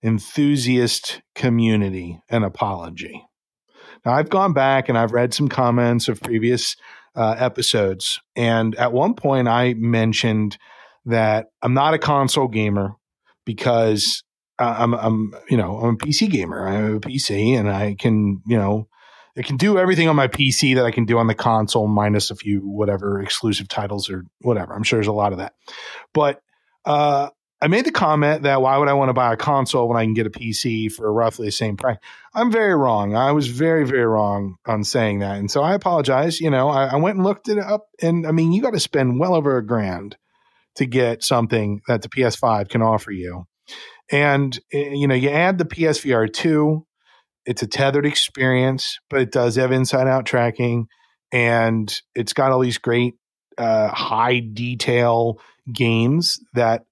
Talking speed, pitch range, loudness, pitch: 185 wpm, 110-140 Hz, -19 LUFS, 120 Hz